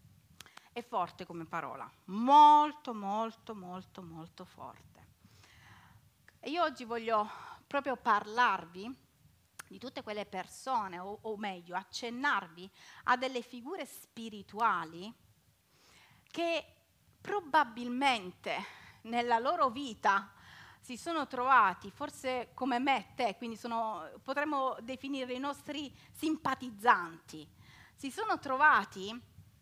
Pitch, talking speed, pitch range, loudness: 235 Hz, 100 wpm, 190-270 Hz, -32 LUFS